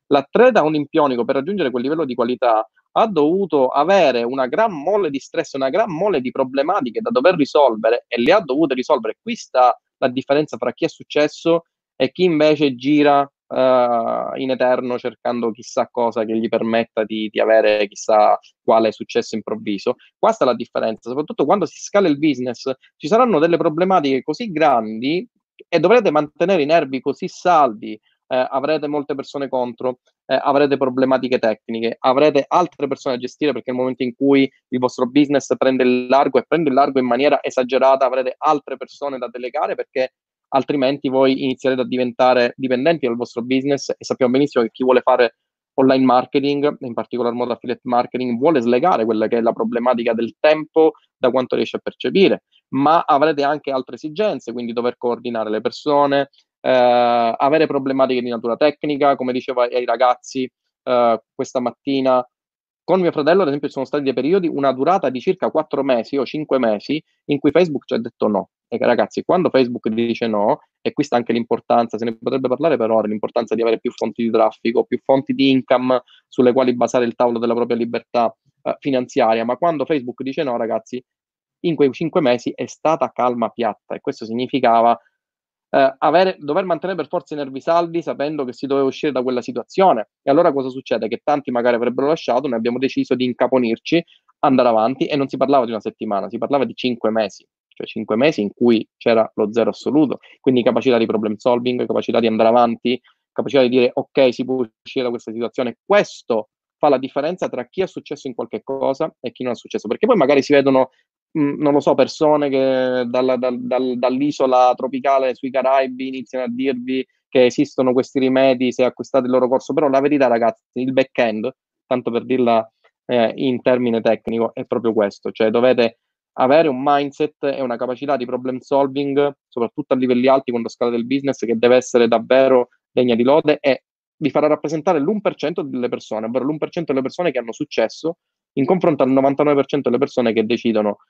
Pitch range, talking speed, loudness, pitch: 120-145 Hz, 190 wpm, -18 LUFS, 130 Hz